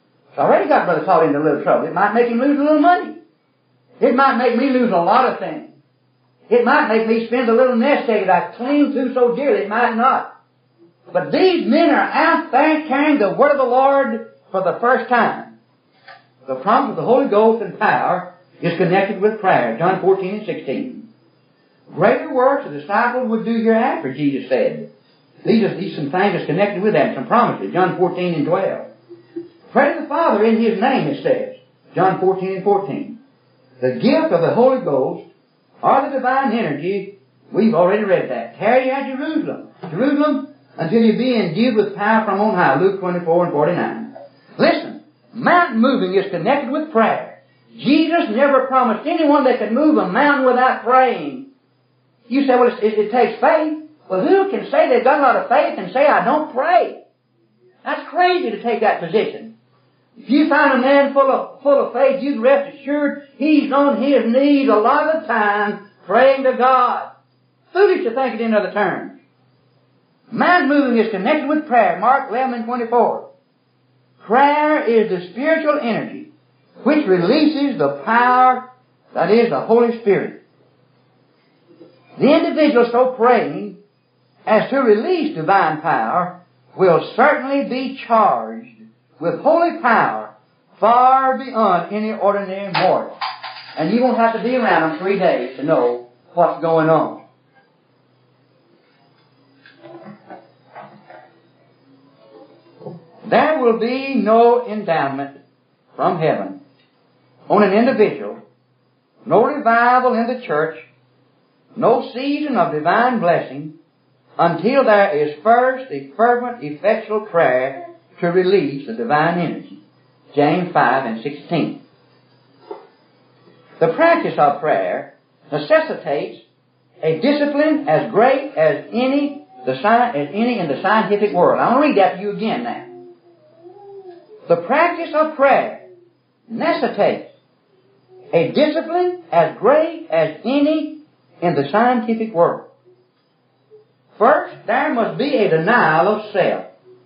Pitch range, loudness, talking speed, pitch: 185-275 Hz, -16 LUFS, 150 wpm, 235 Hz